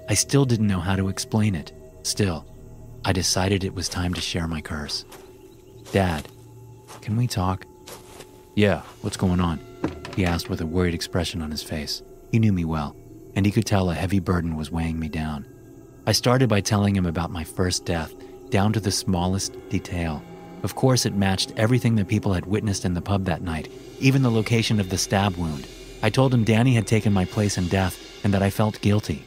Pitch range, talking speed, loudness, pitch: 90-110 Hz, 205 wpm, -24 LUFS, 95 Hz